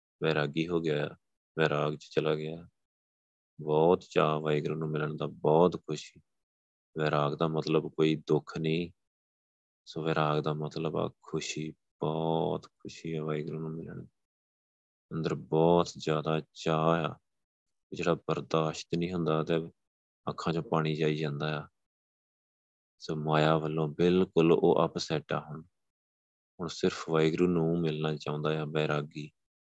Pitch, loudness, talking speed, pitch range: 80 Hz, -30 LUFS, 130 wpm, 75-80 Hz